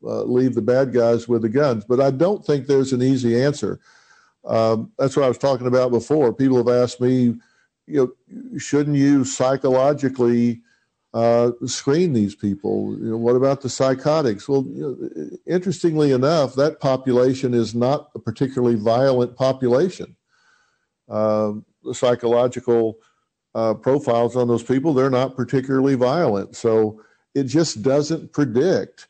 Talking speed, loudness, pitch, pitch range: 150 wpm, -20 LUFS, 125 Hz, 120-140 Hz